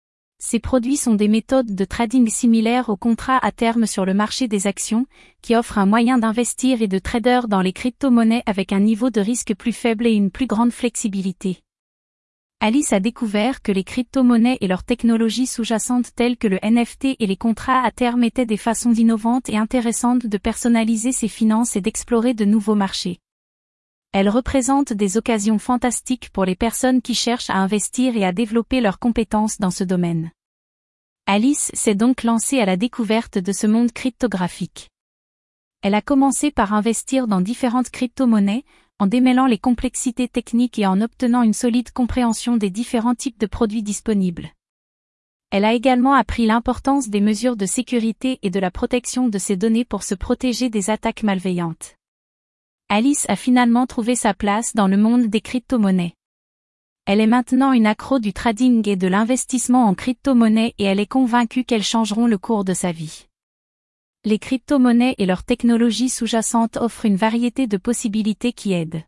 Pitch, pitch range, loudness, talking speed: 230 Hz, 210-250 Hz, -19 LUFS, 175 wpm